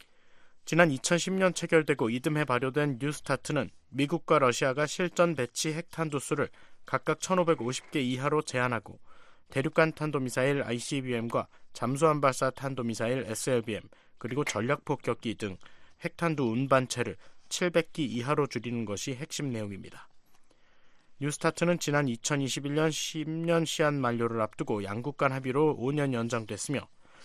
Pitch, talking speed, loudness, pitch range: 140 Hz, 290 characters per minute, -30 LUFS, 120-160 Hz